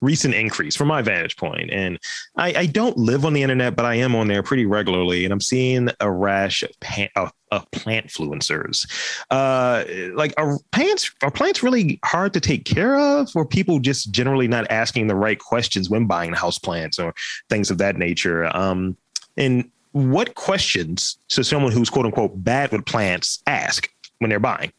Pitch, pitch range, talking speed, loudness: 120 Hz, 100-135 Hz, 190 wpm, -20 LUFS